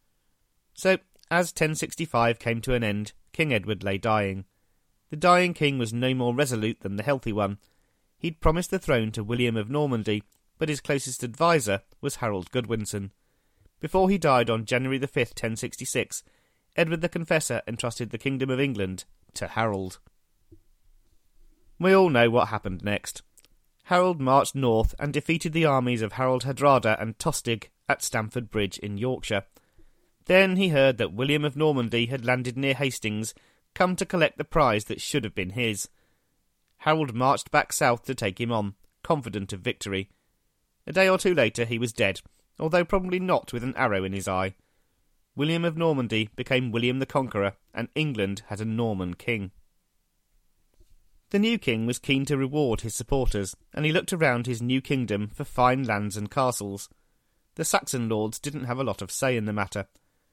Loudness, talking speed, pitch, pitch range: -26 LUFS, 175 wpm, 120 Hz, 105-145 Hz